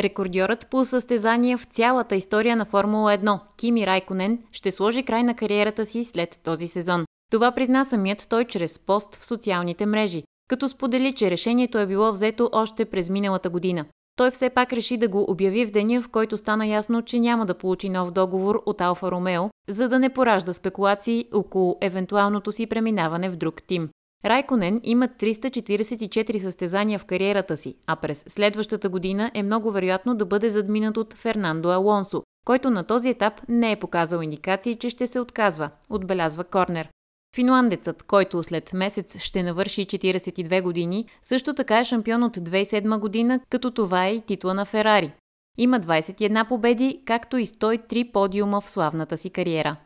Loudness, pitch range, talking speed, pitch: -23 LUFS, 185-235 Hz, 170 wpm, 210 Hz